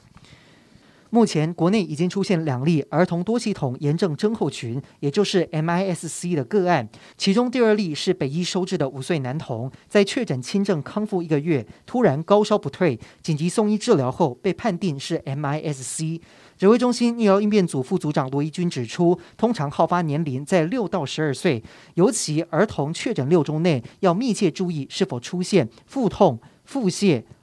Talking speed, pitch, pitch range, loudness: 280 characters per minute, 175 Hz, 145-195 Hz, -22 LUFS